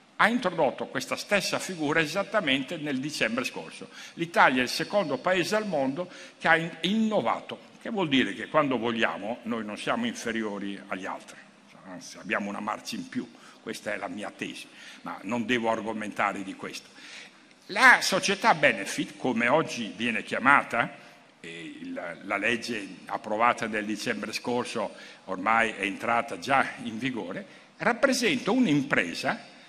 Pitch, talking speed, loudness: 170 Hz, 140 wpm, -27 LUFS